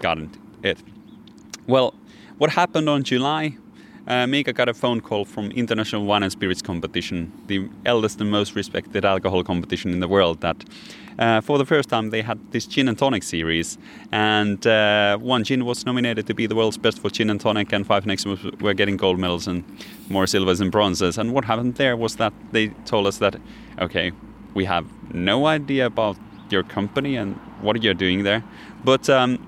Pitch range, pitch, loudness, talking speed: 95-120 Hz, 105 Hz, -22 LUFS, 195 wpm